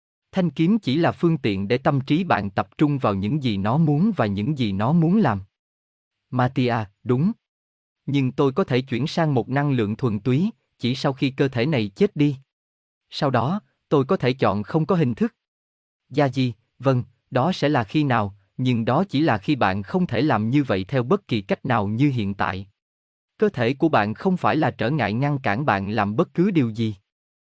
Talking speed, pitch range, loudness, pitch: 210 wpm, 105-155 Hz, -22 LUFS, 125 Hz